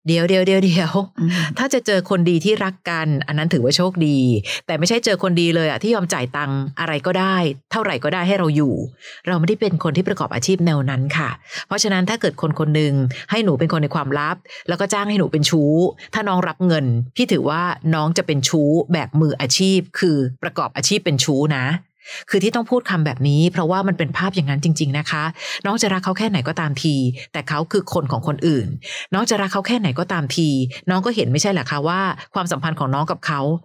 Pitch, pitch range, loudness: 165 Hz, 150-190 Hz, -19 LUFS